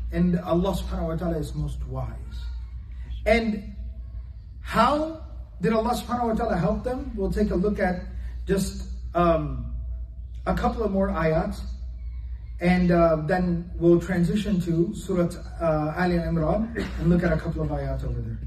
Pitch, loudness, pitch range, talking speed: 170 Hz, -25 LUFS, 130-195 Hz, 155 wpm